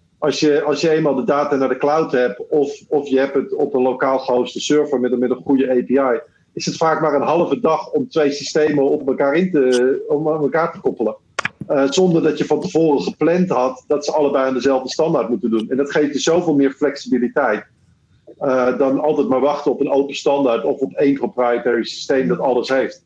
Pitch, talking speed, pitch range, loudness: 140 Hz, 225 wpm, 130-150 Hz, -18 LUFS